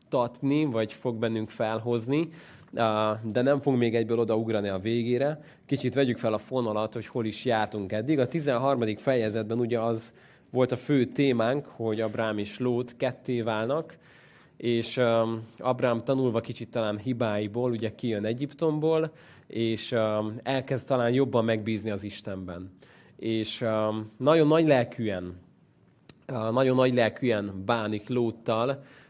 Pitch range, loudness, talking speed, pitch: 110-130 Hz, -28 LUFS, 130 wpm, 115 Hz